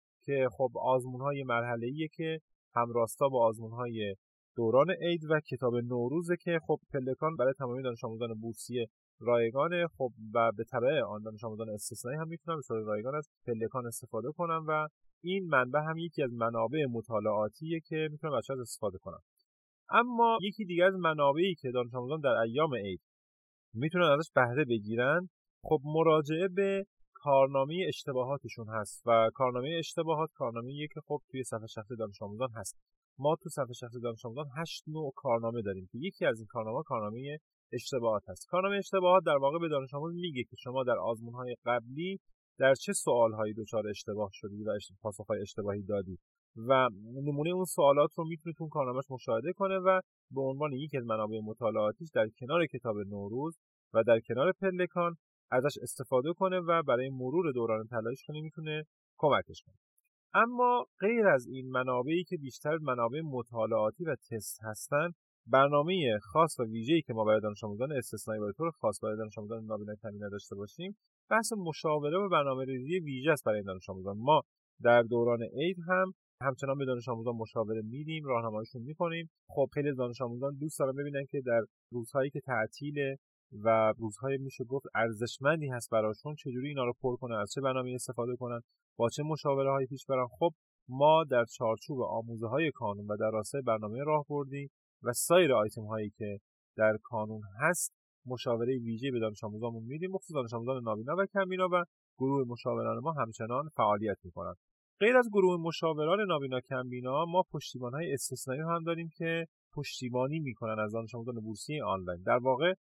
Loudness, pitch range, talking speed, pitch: -33 LUFS, 115-155 Hz, 170 wpm, 130 Hz